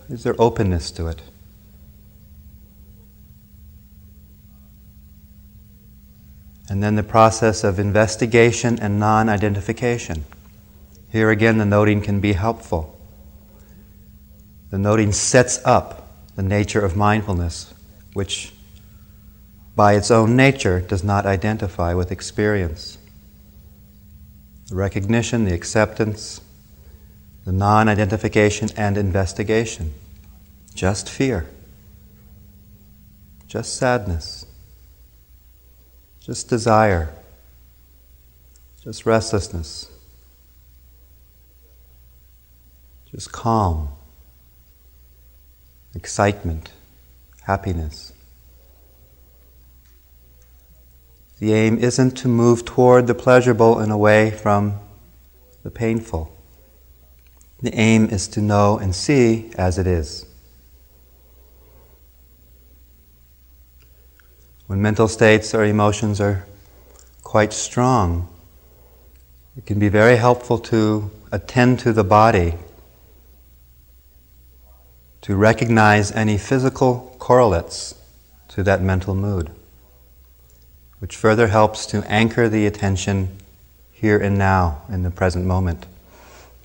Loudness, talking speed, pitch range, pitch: -18 LUFS, 85 wpm, 65-105 Hz, 95 Hz